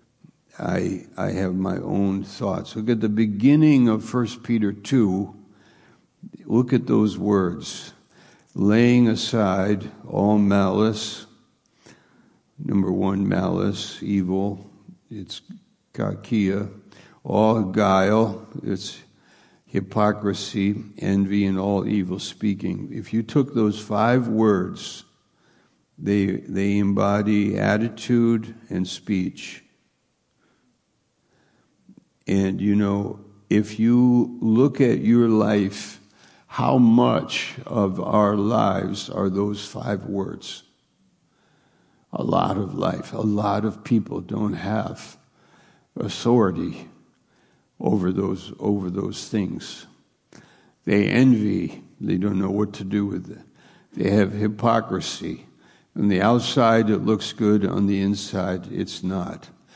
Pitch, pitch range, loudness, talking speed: 105 Hz, 100-110 Hz, -22 LUFS, 105 wpm